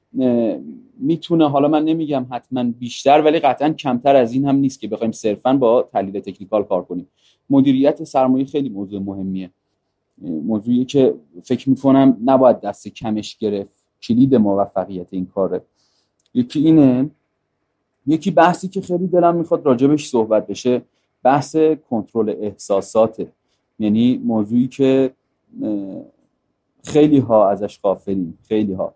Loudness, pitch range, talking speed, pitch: -17 LUFS, 105-150 Hz, 125 wpm, 130 Hz